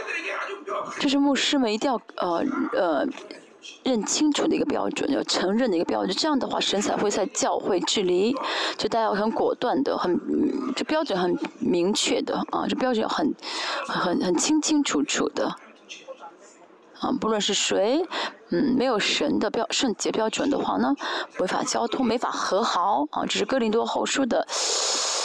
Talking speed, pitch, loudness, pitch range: 240 characters per minute, 290 Hz, -24 LUFS, 250-315 Hz